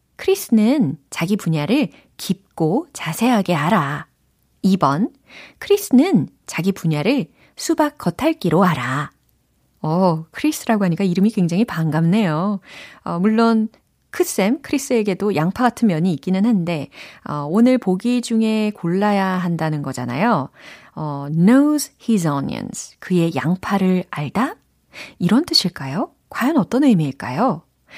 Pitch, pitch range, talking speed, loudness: 195 Hz, 165-245 Hz, 280 characters per minute, -19 LUFS